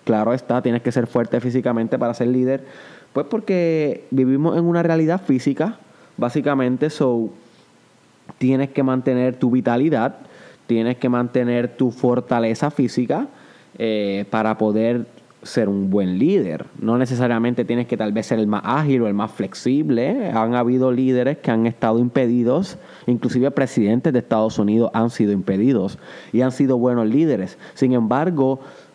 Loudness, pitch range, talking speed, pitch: -20 LUFS, 115-135 Hz, 150 wpm, 125 Hz